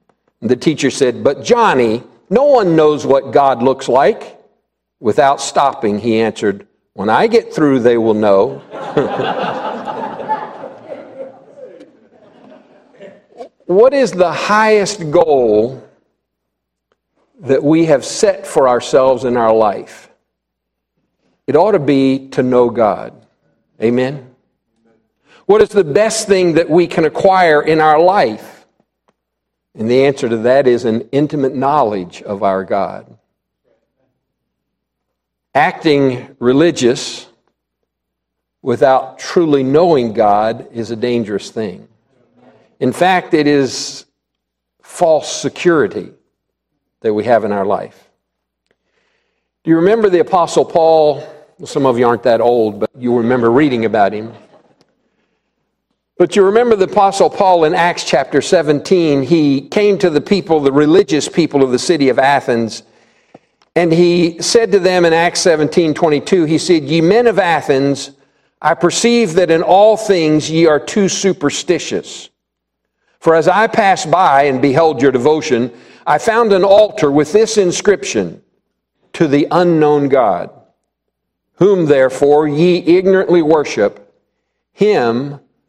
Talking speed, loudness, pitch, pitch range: 130 wpm, -13 LUFS, 150 Hz, 120-180 Hz